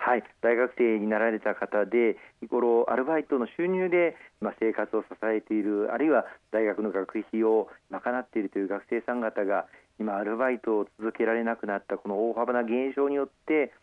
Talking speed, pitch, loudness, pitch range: 355 characters per minute, 110 Hz, -28 LUFS, 105-125 Hz